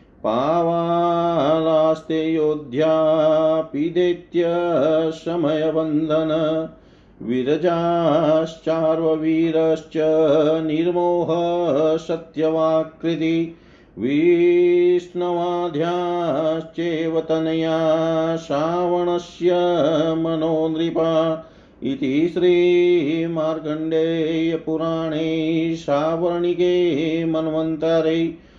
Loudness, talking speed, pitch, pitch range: -20 LUFS, 30 wpm, 160 Hz, 160-170 Hz